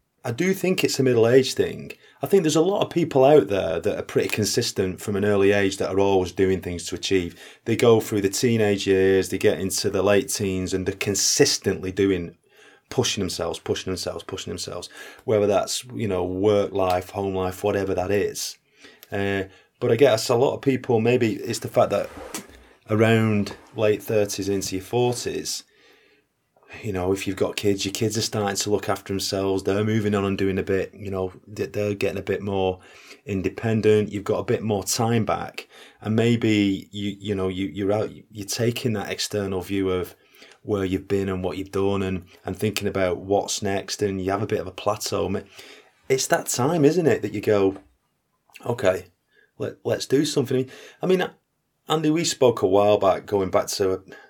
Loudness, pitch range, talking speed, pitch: -23 LUFS, 95-110 Hz, 200 wpm, 100 Hz